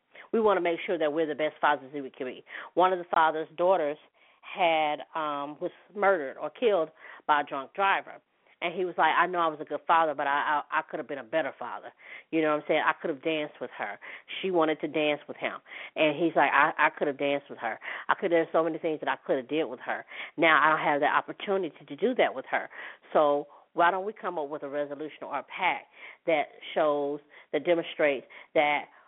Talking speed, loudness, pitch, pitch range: 245 wpm, -28 LUFS, 160 Hz, 145-170 Hz